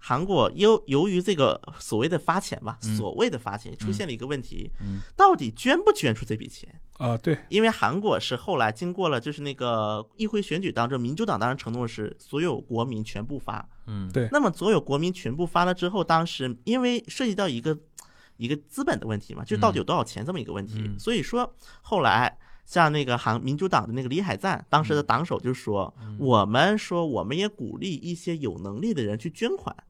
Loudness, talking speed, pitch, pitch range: -26 LUFS, 320 characters per minute, 145 Hz, 115-185 Hz